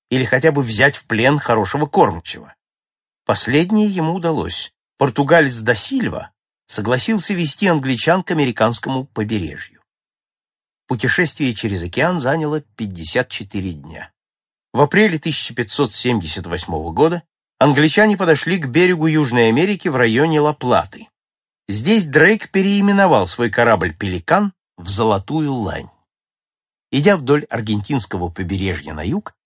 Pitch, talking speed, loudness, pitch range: 135 Hz, 110 wpm, -17 LUFS, 110-165 Hz